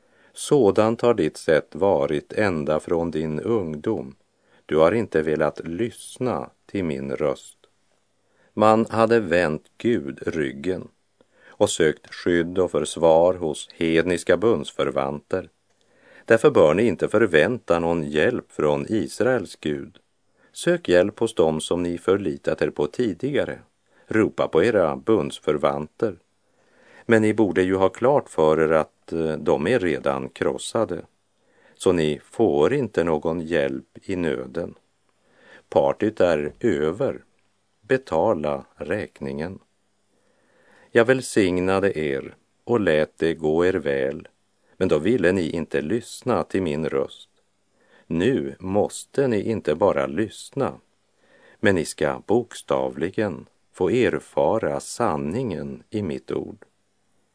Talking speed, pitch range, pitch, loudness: 120 wpm, 75-100 Hz, 85 Hz, -23 LUFS